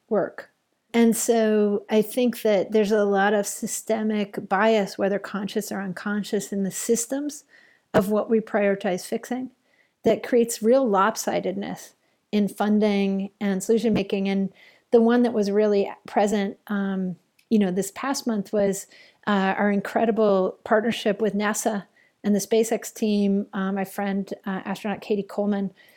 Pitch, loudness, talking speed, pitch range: 210 Hz, -24 LUFS, 150 wpm, 200-225 Hz